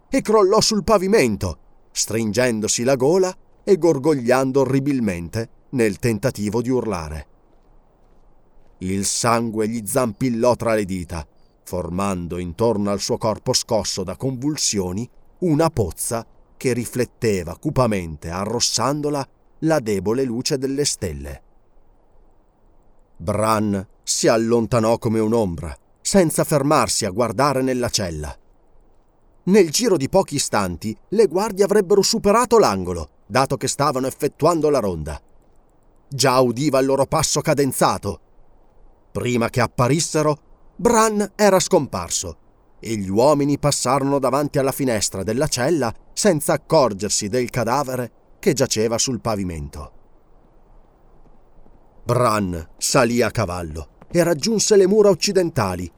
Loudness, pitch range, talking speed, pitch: -20 LUFS, 100-150 Hz, 115 wpm, 120 Hz